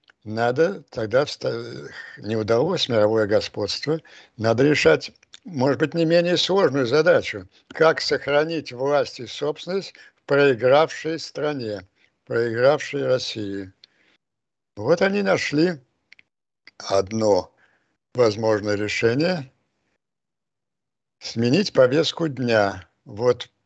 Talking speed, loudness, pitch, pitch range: 85 wpm, -21 LUFS, 130 Hz, 110-160 Hz